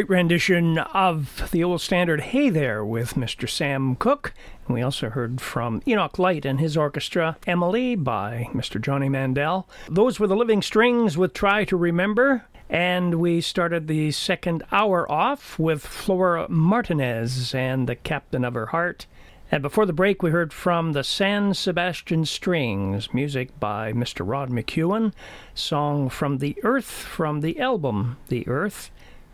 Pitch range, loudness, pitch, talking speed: 135-185 Hz, -23 LUFS, 165 Hz, 155 wpm